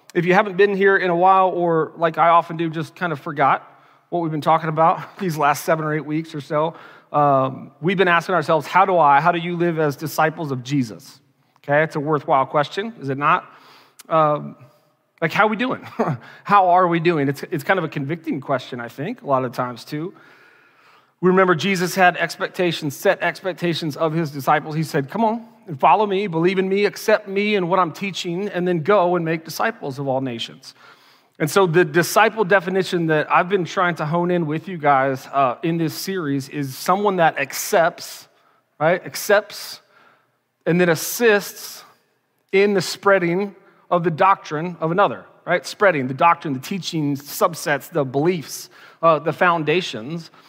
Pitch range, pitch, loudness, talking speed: 150-185 Hz, 170 Hz, -19 LUFS, 195 wpm